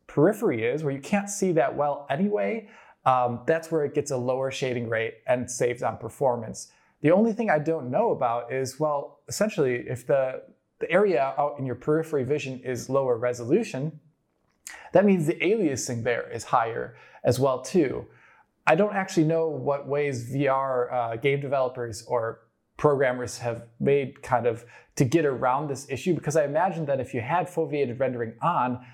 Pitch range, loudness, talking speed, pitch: 125-155 Hz, -26 LUFS, 175 wpm, 140 Hz